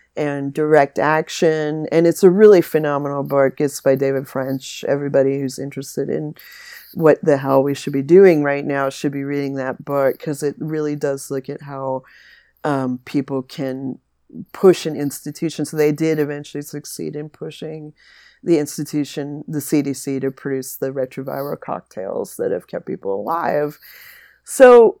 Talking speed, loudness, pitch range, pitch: 160 wpm, -18 LUFS, 135-155 Hz, 145 Hz